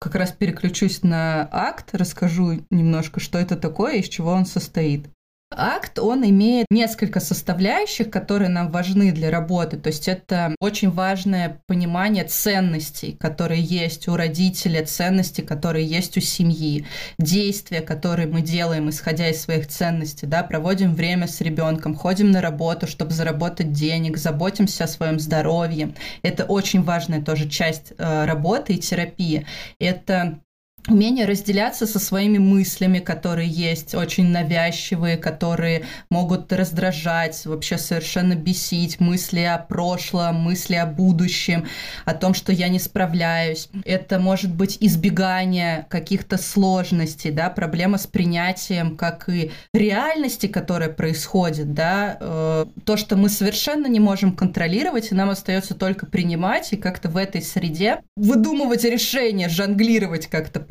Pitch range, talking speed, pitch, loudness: 165-195 Hz, 135 wpm, 180 Hz, -21 LUFS